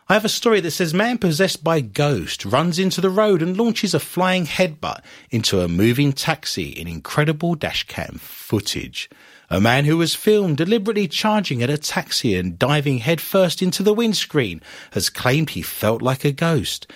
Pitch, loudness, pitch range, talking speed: 160 Hz, -19 LUFS, 130-190 Hz, 175 wpm